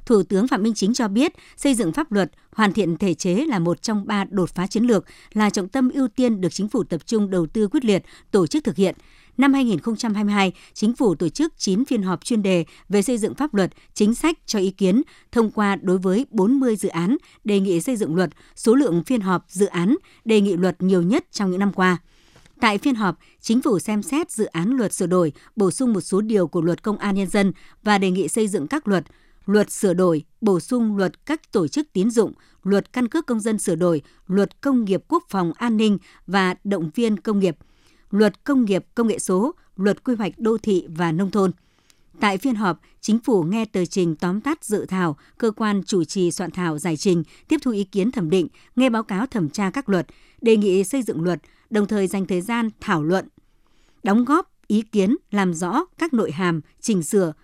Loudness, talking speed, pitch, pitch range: -21 LUFS, 230 wpm, 205 Hz, 185-230 Hz